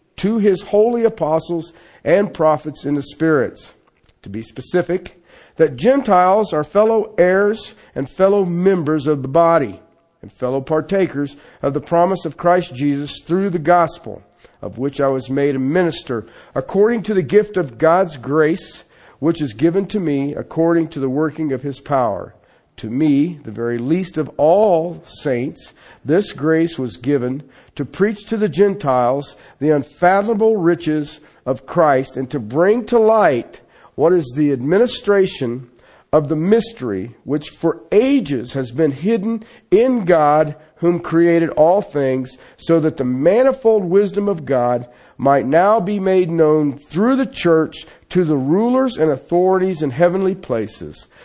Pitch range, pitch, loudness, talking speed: 140-190 Hz, 160 Hz, -17 LUFS, 150 wpm